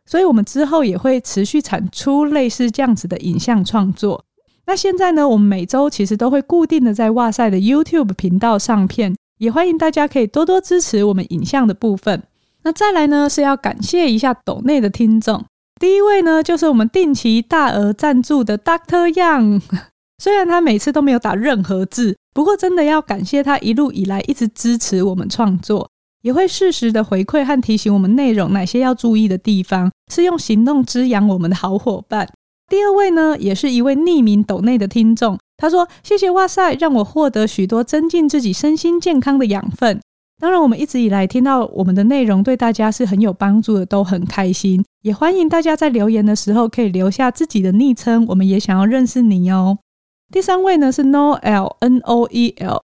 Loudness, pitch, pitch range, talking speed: -15 LUFS, 235 Hz, 205-300 Hz, 320 characters per minute